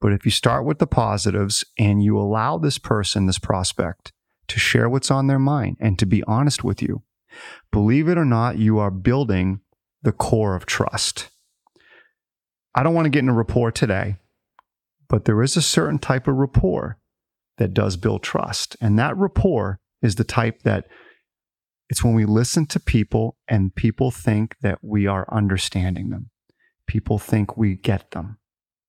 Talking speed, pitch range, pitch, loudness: 175 wpm, 100-125 Hz, 110 Hz, -21 LUFS